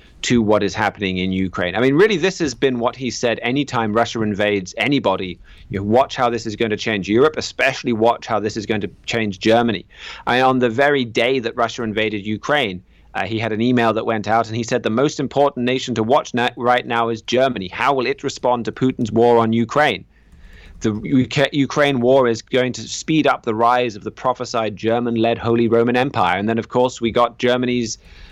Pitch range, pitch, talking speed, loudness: 110-125 Hz, 115 Hz, 215 wpm, -18 LUFS